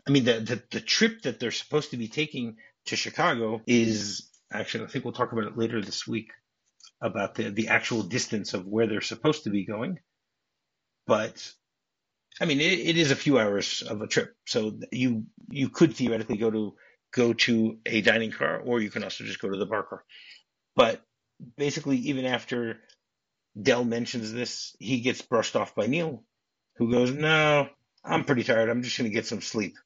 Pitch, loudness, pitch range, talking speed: 120 Hz, -27 LUFS, 110-140 Hz, 195 wpm